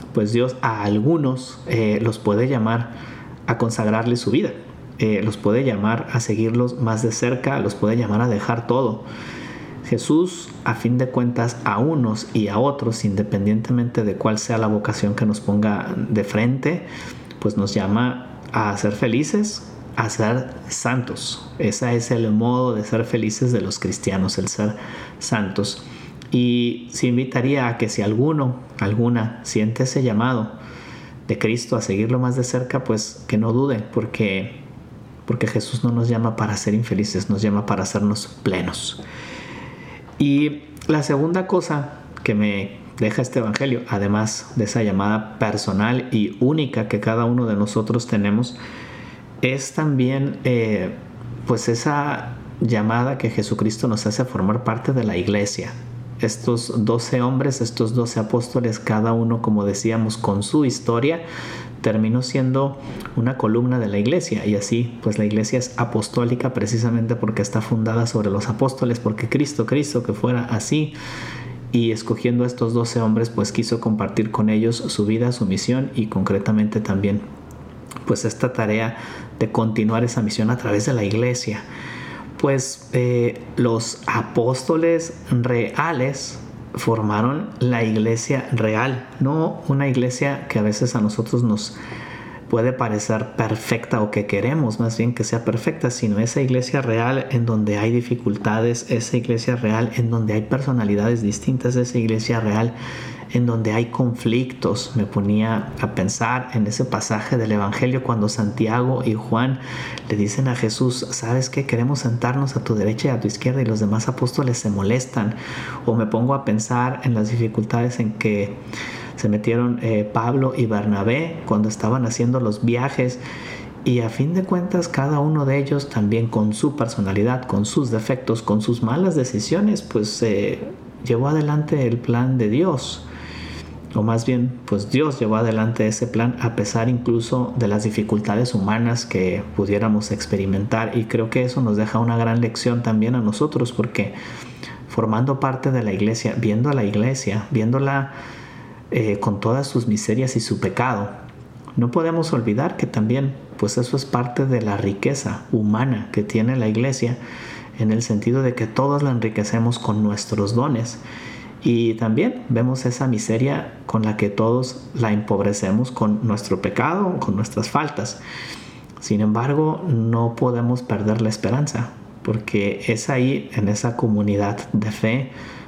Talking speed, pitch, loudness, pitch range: 155 wpm, 115 Hz, -21 LUFS, 110-125 Hz